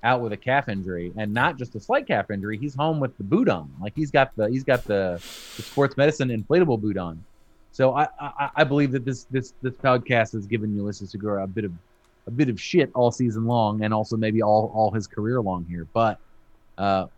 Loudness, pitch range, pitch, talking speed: -24 LUFS, 105-130 Hz, 115 Hz, 230 wpm